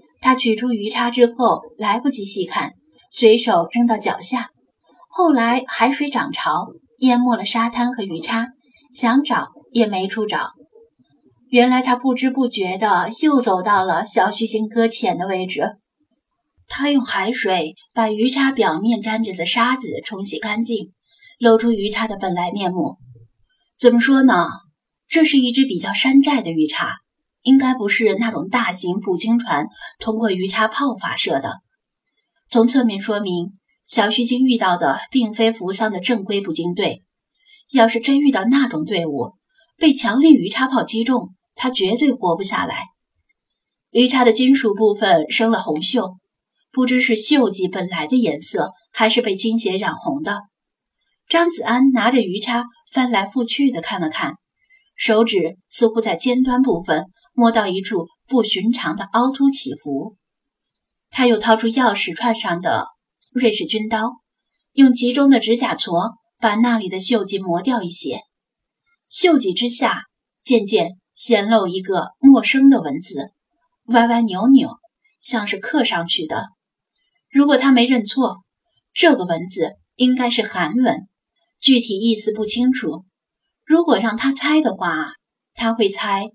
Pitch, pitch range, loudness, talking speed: 235 Hz, 205-260 Hz, -17 LUFS, 220 characters per minute